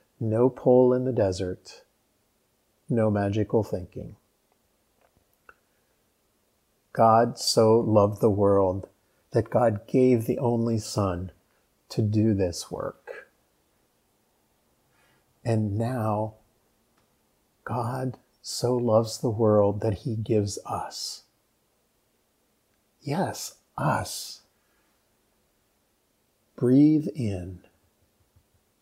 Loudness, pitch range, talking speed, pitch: -25 LUFS, 100-120 Hz, 80 wpm, 110 Hz